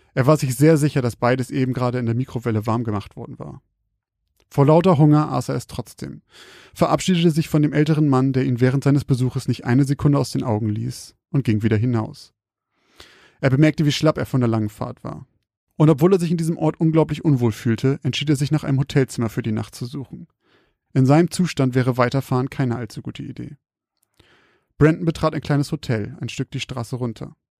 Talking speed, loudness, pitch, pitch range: 205 wpm, -20 LUFS, 135 Hz, 125-155 Hz